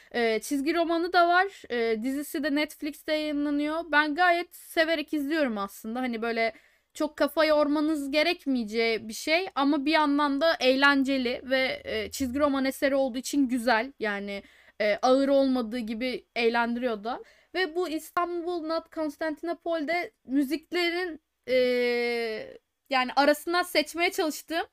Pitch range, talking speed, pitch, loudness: 255-325 Hz, 130 wpm, 295 Hz, -27 LUFS